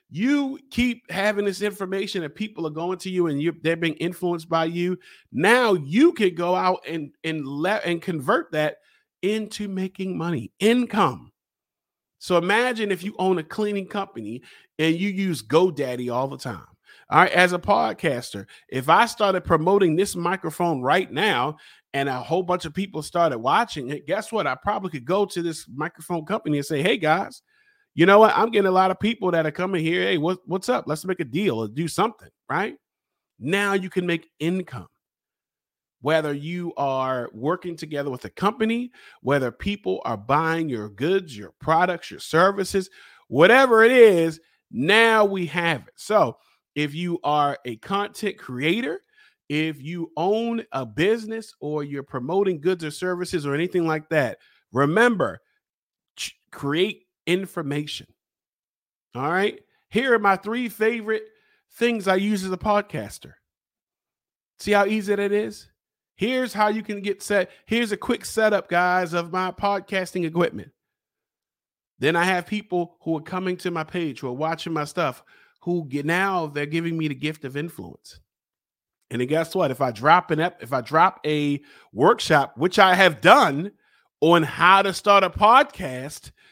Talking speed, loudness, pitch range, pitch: 170 wpm, -22 LUFS, 155-200 Hz, 180 Hz